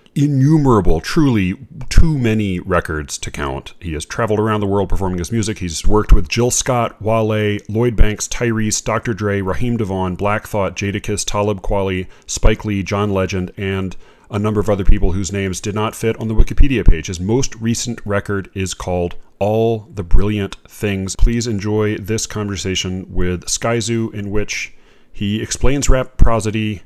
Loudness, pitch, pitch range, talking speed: -18 LUFS, 105 Hz, 95-115 Hz, 170 wpm